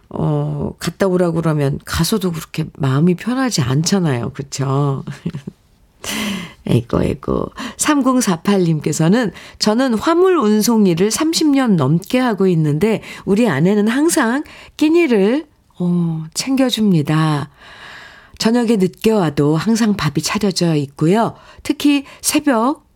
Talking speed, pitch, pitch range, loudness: 240 characters per minute, 195 Hz, 160-235 Hz, -16 LUFS